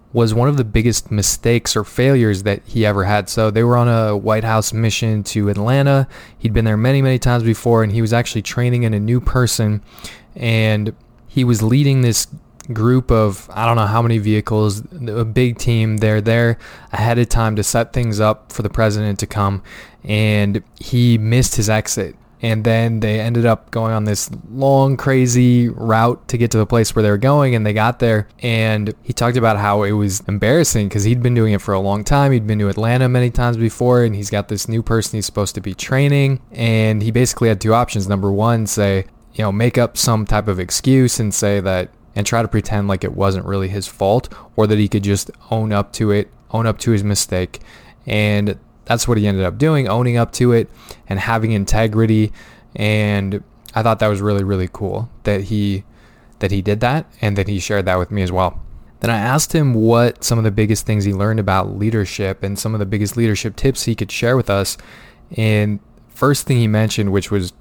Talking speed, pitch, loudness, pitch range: 220 wpm, 110 Hz, -17 LUFS, 105-120 Hz